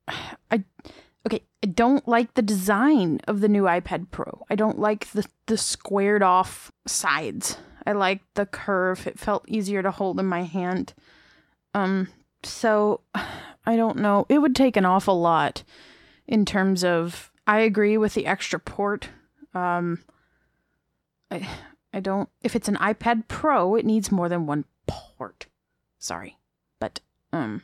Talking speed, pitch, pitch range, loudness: 150 wpm, 205 Hz, 190-220 Hz, -24 LUFS